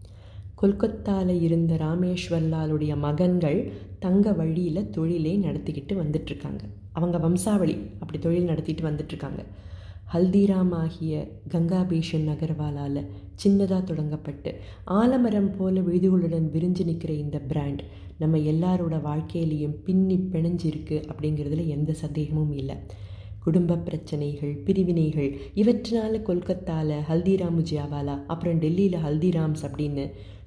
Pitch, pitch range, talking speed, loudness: 160 Hz, 150-180 Hz, 95 wpm, -26 LUFS